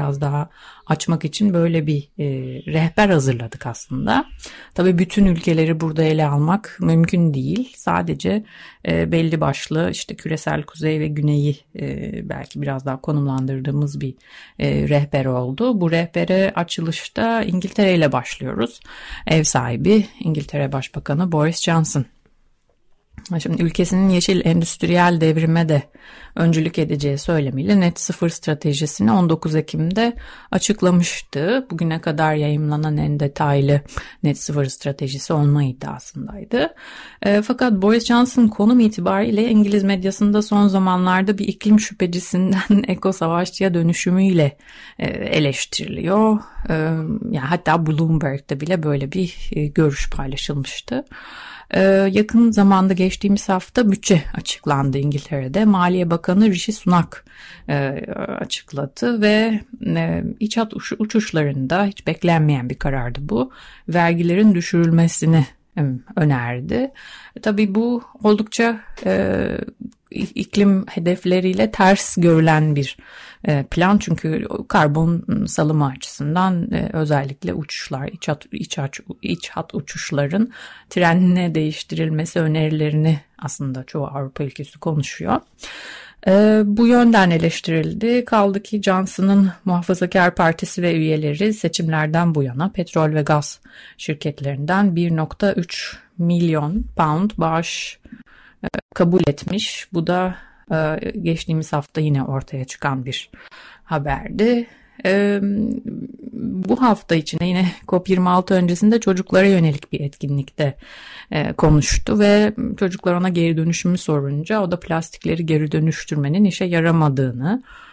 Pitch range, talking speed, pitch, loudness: 150-200 Hz, 105 wpm, 170 Hz, -19 LUFS